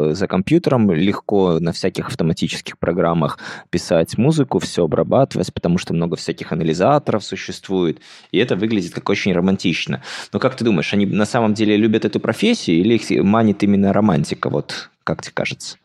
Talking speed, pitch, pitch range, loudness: 165 wpm, 100 Hz, 90-110 Hz, -18 LUFS